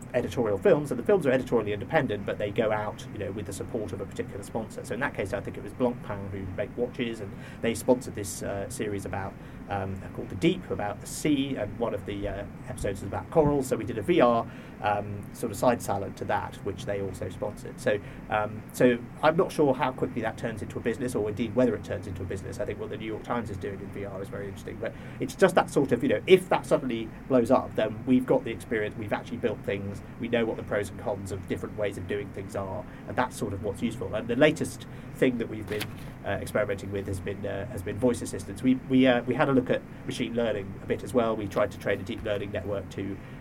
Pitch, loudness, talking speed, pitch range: 110 Hz, -29 LUFS, 265 wpm, 100-125 Hz